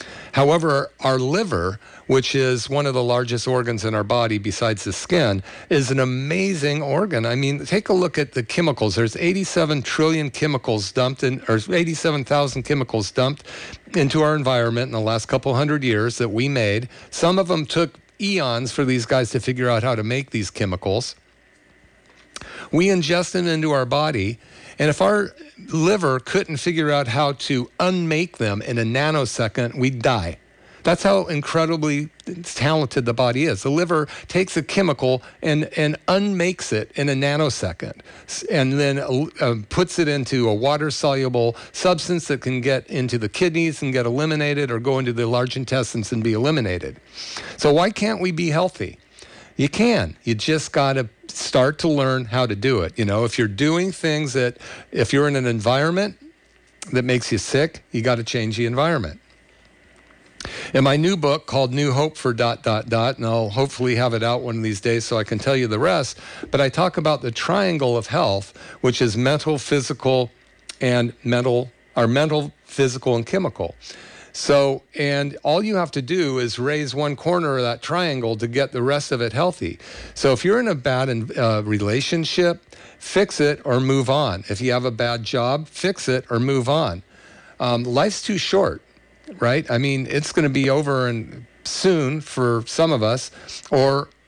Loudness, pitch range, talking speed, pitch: -21 LUFS, 120-155 Hz, 180 wpm, 135 Hz